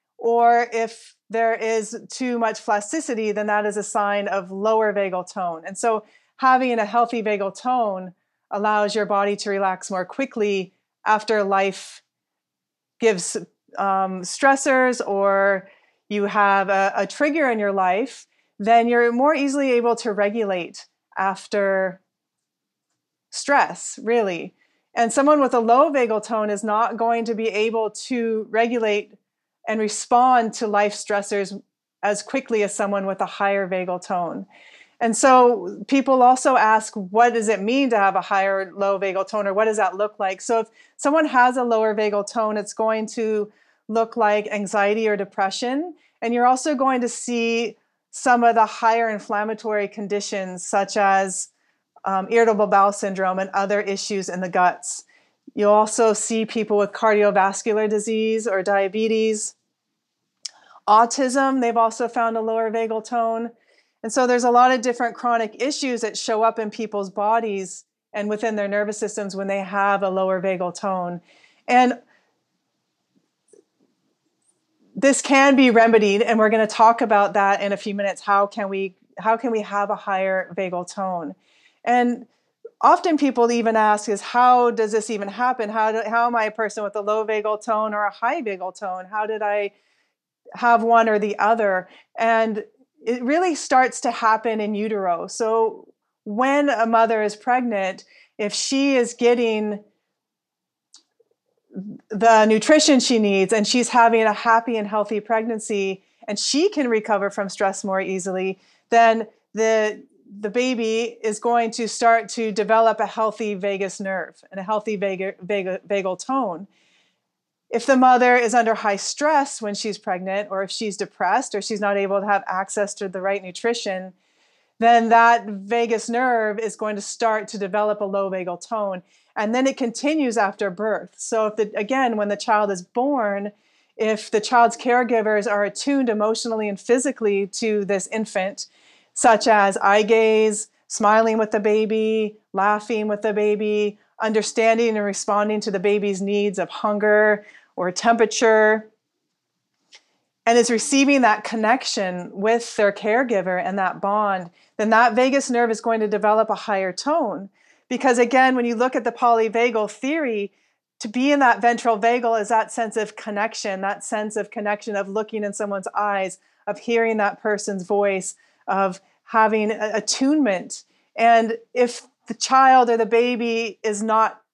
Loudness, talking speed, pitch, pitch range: -20 LUFS, 160 wpm, 220 Hz, 205-235 Hz